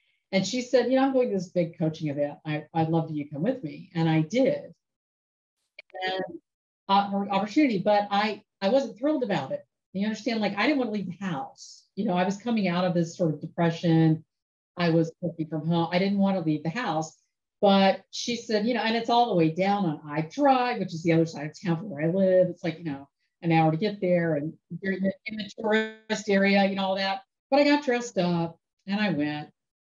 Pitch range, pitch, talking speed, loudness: 165-215 Hz, 190 Hz, 240 wpm, -26 LUFS